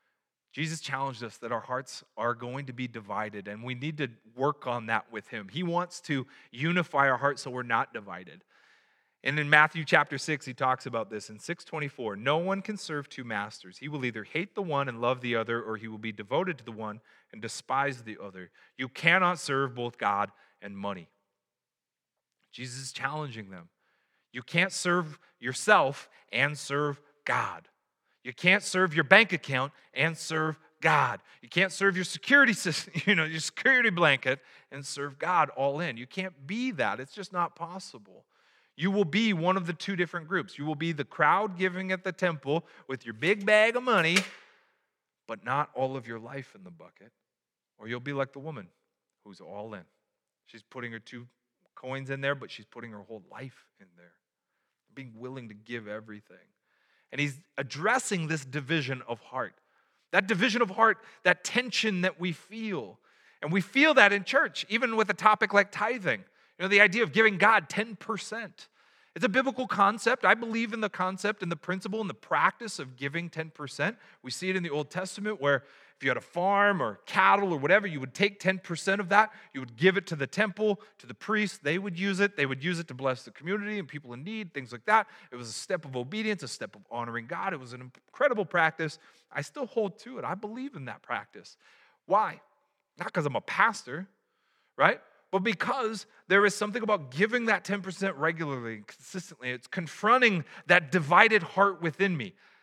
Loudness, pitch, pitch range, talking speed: -28 LUFS, 160 Hz, 130-200 Hz, 200 wpm